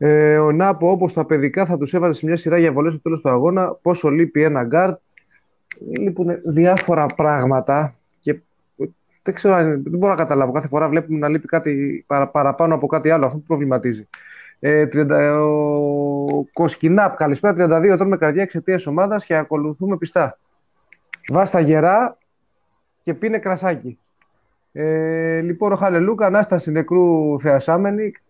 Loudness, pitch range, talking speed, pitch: -18 LUFS, 150-180 Hz, 155 wpm, 160 Hz